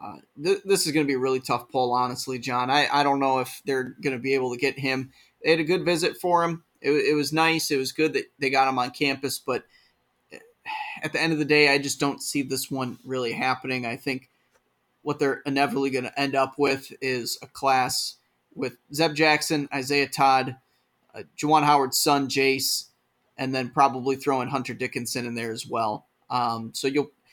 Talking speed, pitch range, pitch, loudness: 215 wpm, 130-145 Hz, 135 Hz, -24 LUFS